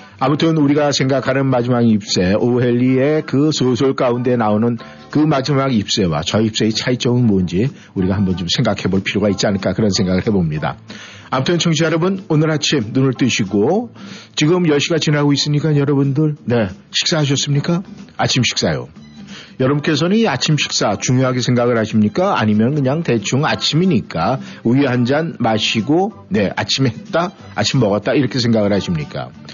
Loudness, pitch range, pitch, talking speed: -16 LUFS, 110-150 Hz, 130 Hz, 365 characters per minute